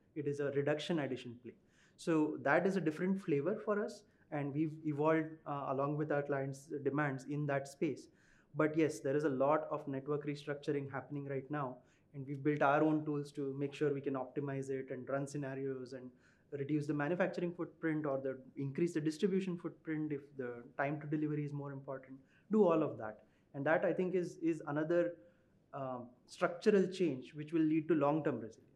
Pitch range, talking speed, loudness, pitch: 140-160 Hz, 195 wpm, -37 LUFS, 145 Hz